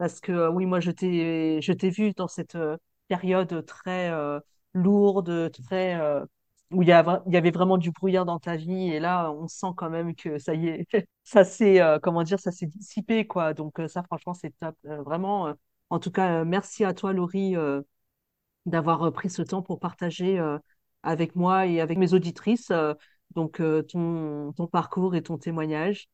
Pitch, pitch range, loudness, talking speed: 175 Hz, 165-185 Hz, -26 LUFS, 195 wpm